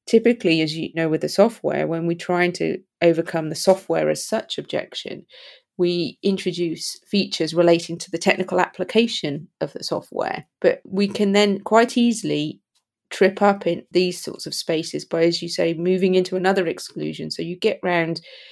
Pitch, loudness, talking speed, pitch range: 180 Hz, -21 LUFS, 170 wpm, 165-200 Hz